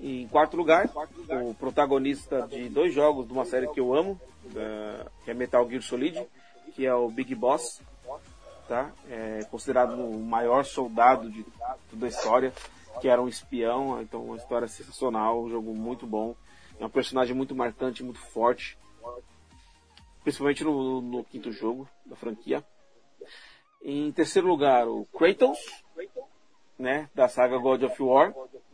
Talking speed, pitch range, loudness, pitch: 145 wpm, 115-135 Hz, -27 LUFS, 125 Hz